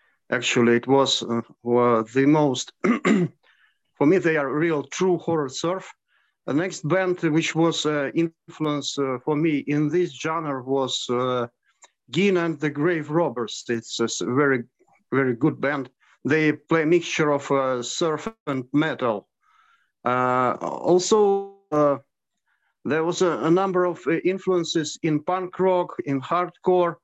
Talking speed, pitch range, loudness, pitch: 150 wpm, 135-175 Hz, -23 LUFS, 155 Hz